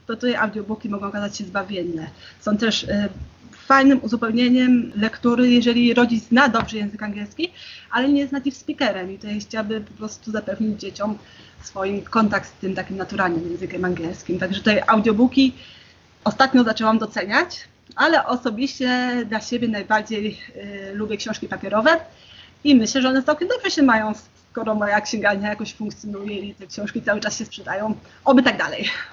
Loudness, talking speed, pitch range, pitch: -21 LUFS, 165 wpm, 205-245 Hz, 220 Hz